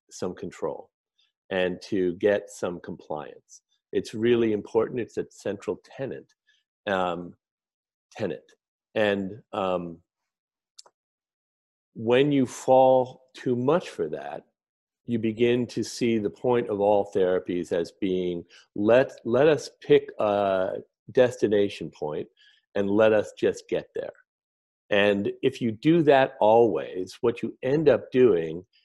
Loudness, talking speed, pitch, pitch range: -25 LUFS, 125 wpm, 115 Hz, 95-135 Hz